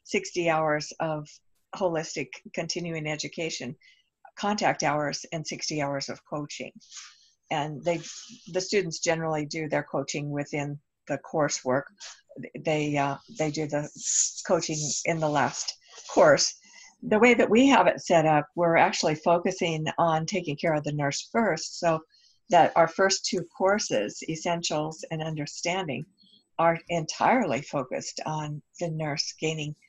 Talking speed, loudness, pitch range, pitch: 135 wpm, -27 LUFS, 150-180 Hz, 160 Hz